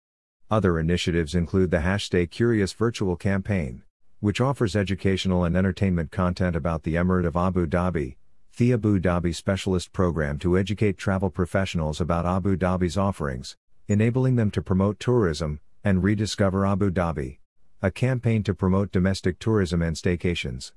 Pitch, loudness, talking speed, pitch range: 95 Hz, -24 LUFS, 145 wpm, 85-100 Hz